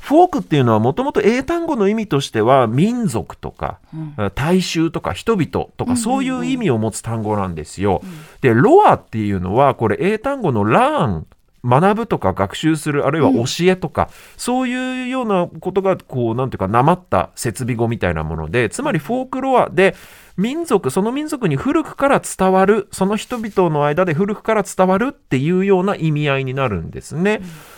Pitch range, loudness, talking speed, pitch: 130-220 Hz, -17 LUFS, 375 characters per minute, 180 Hz